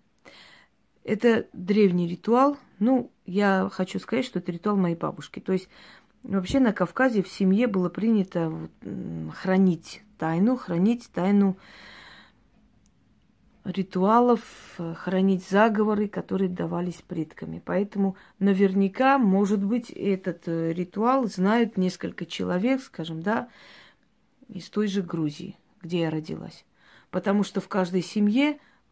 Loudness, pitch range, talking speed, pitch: -25 LUFS, 180-220 Hz, 110 wpm, 195 Hz